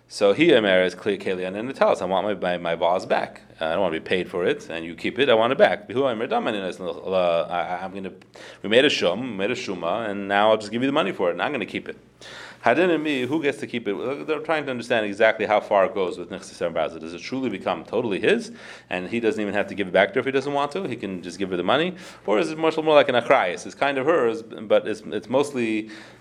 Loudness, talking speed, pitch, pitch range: -23 LUFS, 285 wpm, 105 Hz, 95-135 Hz